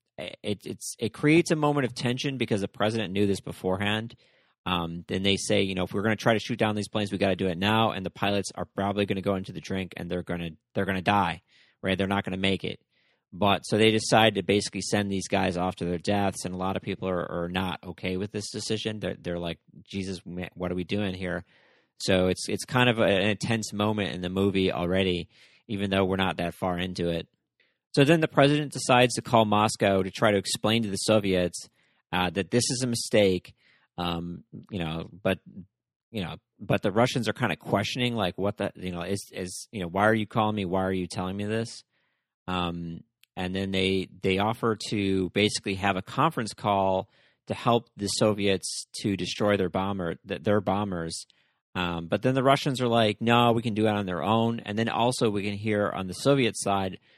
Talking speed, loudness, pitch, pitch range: 230 wpm, -27 LUFS, 100 Hz, 95-110 Hz